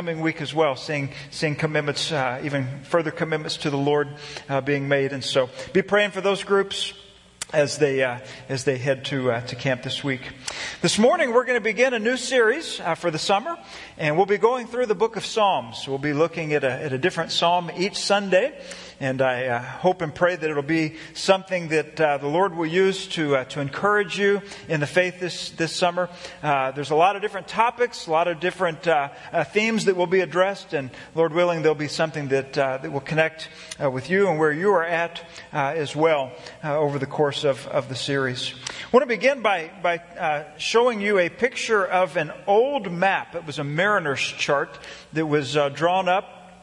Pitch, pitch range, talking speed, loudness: 165 Hz, 145-190 Hz, 215 wpm, -23 LUFS